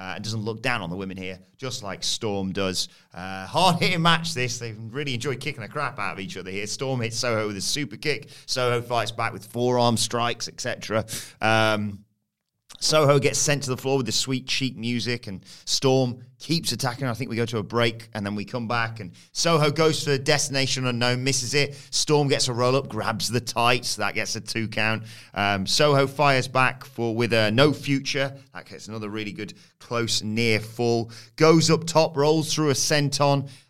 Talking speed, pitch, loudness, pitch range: 205 wpm, 120 Hz, -24 LUFS, 110-140 Hz